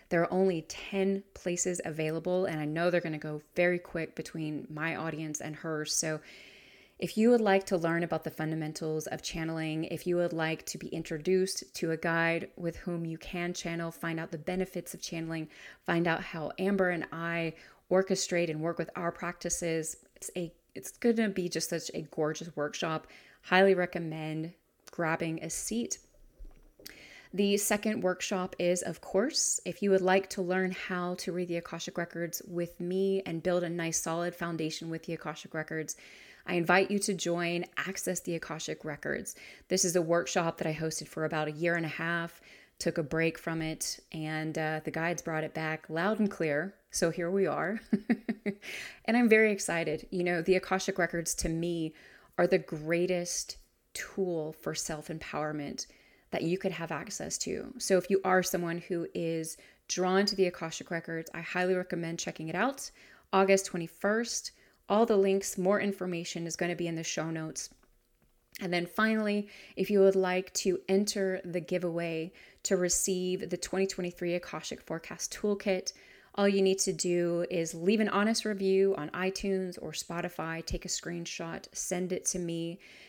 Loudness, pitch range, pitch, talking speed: -32 LUFS, 165-190 Hz, 175 Hz, 180 wpm